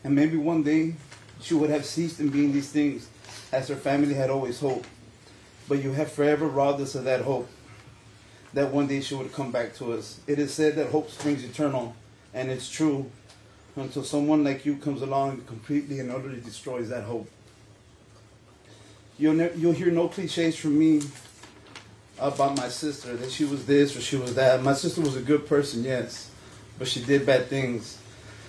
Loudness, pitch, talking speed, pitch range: -26 LUFS, 135 Hz, 190 wpm, 120-145 Hz